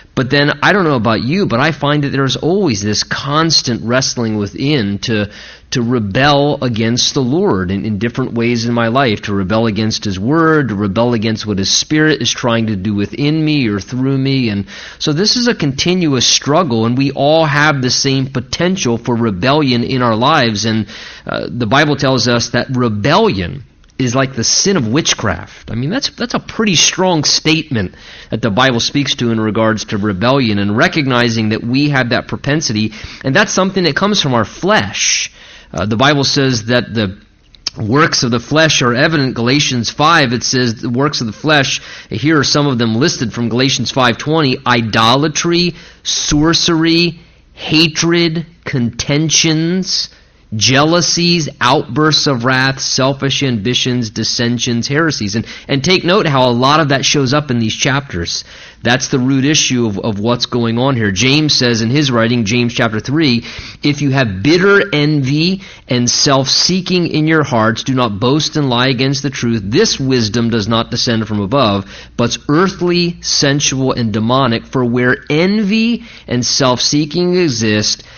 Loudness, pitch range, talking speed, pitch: -13 LUFS, 115-150 Hz, 175 wpm, 130 Hz